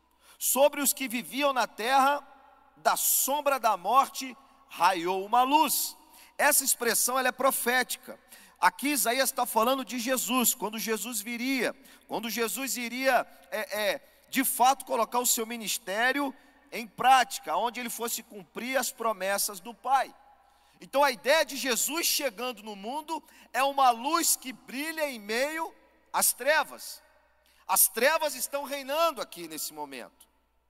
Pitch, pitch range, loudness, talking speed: 260 Hz, 230-285 Hz, -27 LUFS, 140 wpm